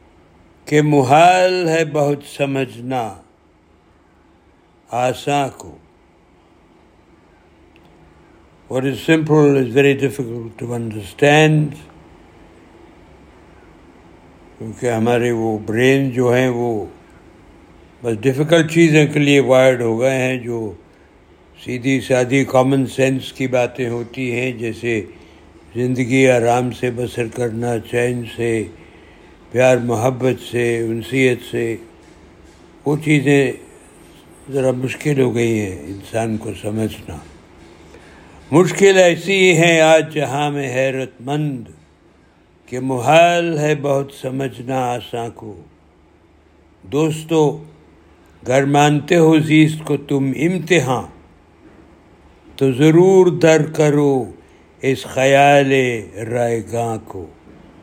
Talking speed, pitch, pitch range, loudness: 100 wpm, 125 Hz, 110-140 Hz, -16 LUFS